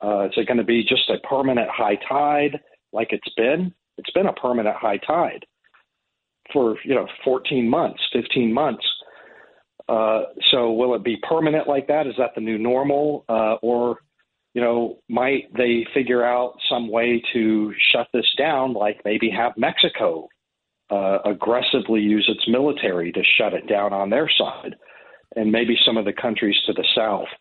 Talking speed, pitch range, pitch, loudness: 175 wpm, 110-130 Hz, 120 Hz, -20 LUFS